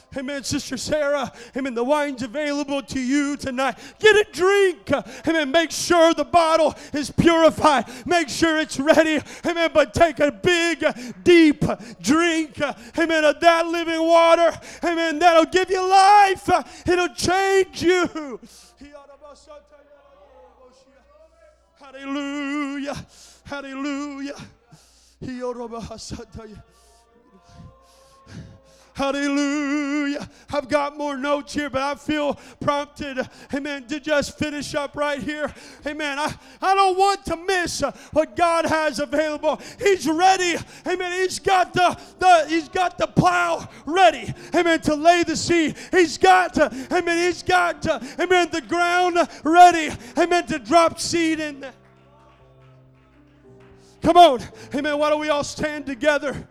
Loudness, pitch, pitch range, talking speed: -20 LUFS, 300 Hz, 280-335 Hz, 120 wpm